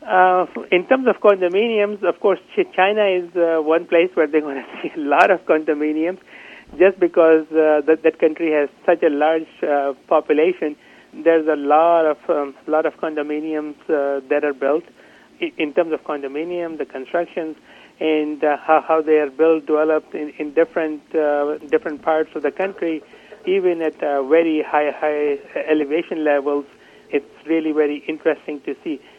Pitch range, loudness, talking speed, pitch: 150-170 Hz, -19 LUFS, 170 wpm, 155 Hz